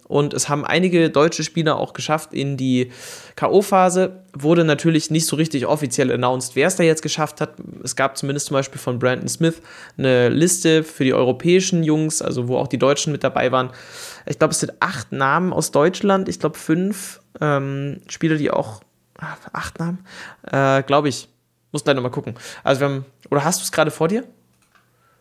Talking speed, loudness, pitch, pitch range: 195 wpm, -19 LUFS, 150 Hz, 135-165 Hz